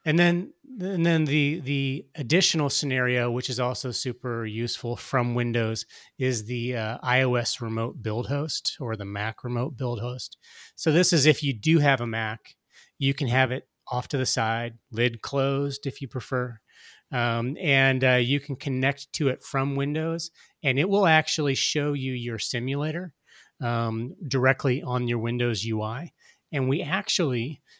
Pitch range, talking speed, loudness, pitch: 120-145 Hz, 165 wpm, -26 LUFS, 130 Hz